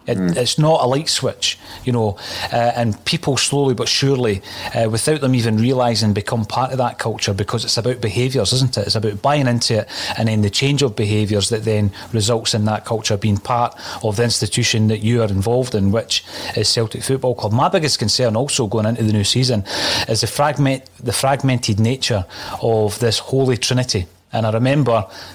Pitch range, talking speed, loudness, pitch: 110-130 Hz, 200 wpm, -18 LUFS, 115 Hz